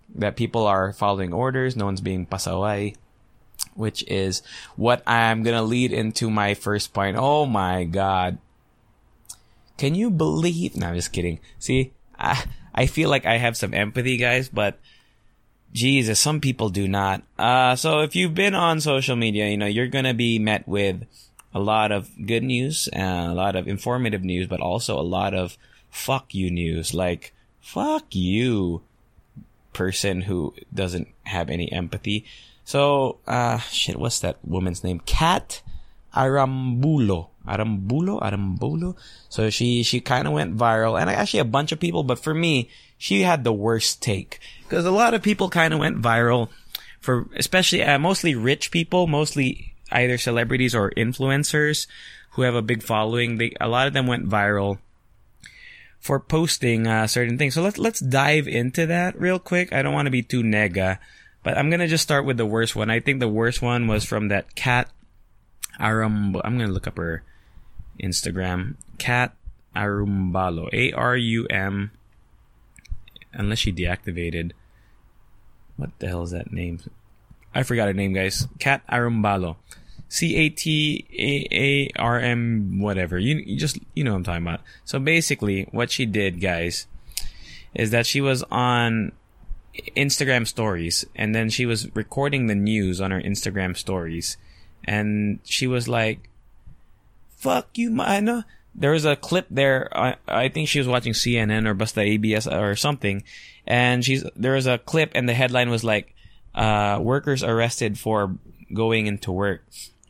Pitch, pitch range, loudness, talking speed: 115 Hz, 100-135 Hz, -22 LUFS, 165 wpm